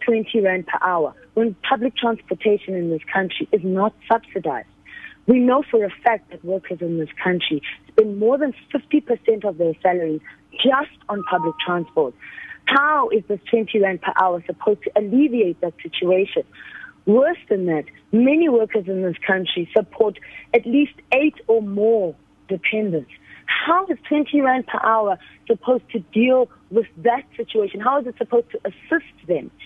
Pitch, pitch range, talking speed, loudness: 220 Hz, 185-255 Hz, 160 wpm, -20 LUFS